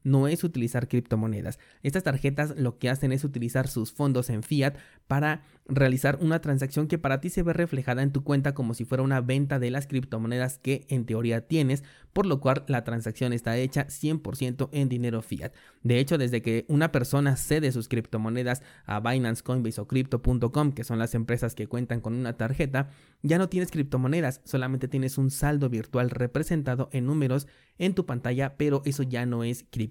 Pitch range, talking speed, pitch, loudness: 120-140 Hz, 190 wpm, 130 Hz, -28 LUFS